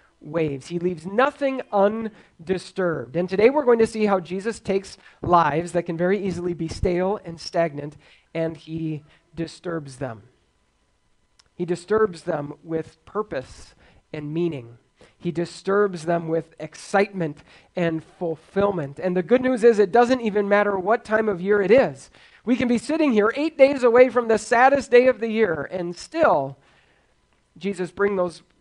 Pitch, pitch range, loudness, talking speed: 185 Hz, 165-220 Hz, -22 LUFS, 160 wpm